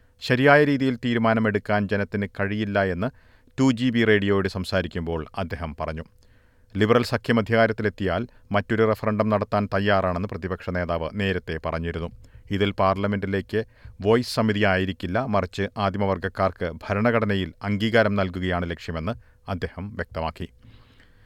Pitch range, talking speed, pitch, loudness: 95-110 Hz, 105 wpm, 100 Hz, -24 LUFS